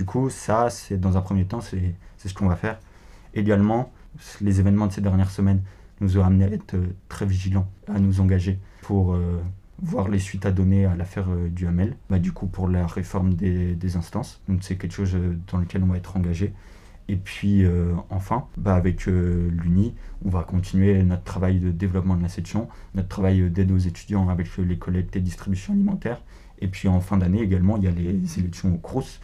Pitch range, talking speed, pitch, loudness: 90-100 Hz, 220 wpm, 95 Hz, -24 LUFS